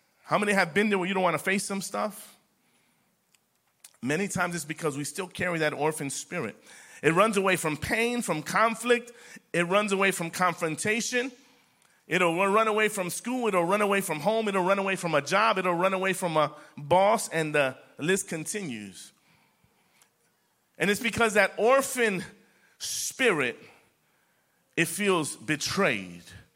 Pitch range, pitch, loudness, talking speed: 160-205 Hz, 190 Hz, -26 LUFS, 160 wpm